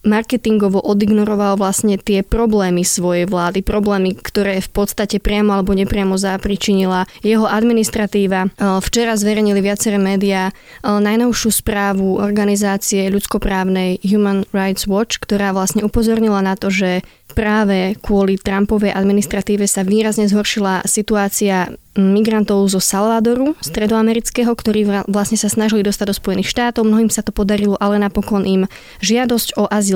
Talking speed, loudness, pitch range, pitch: 130 wpm, -16 LUFS, 195-215 Hz, 205 Hz